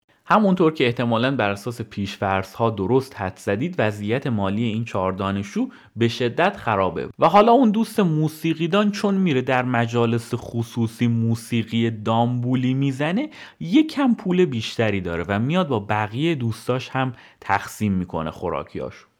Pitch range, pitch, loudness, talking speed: 105-160 Hz, 120 Hz, -22 LUFS, 140 wpm